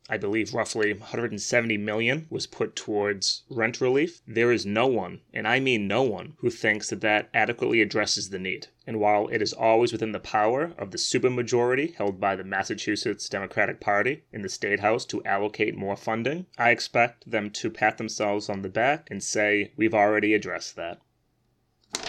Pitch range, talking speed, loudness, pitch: 105-120 Hz, 180 wpm, -26 LUFS, 110 Hz